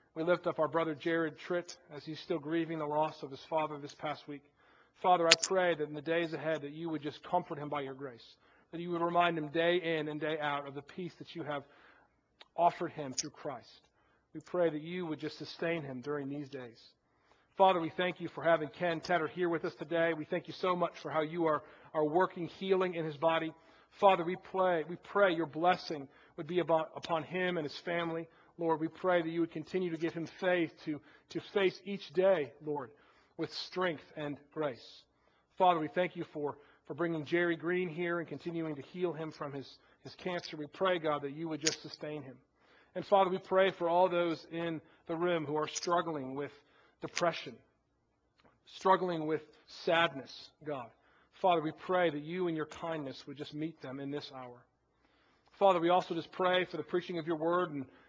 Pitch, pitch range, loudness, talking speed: 165 Hz, 150-175 Hz, -34 LUFS, 210 wpm